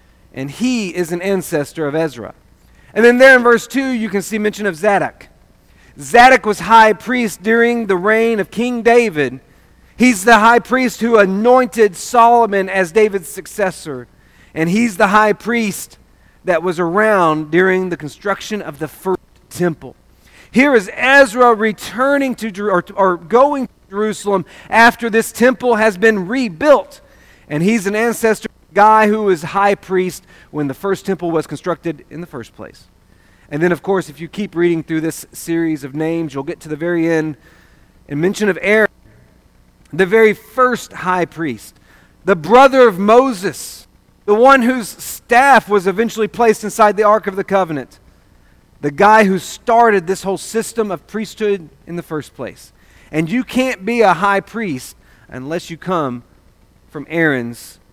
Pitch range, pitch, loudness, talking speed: 165-225 Hz, 195 Hz, -14 LUFS, 165 wpm